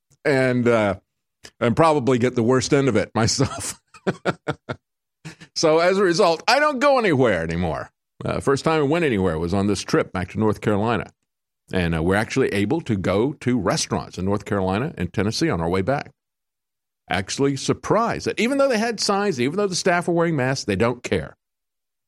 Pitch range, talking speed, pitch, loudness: 100-160 Hz, 190 wpm, 125 Hz, -21 LUFS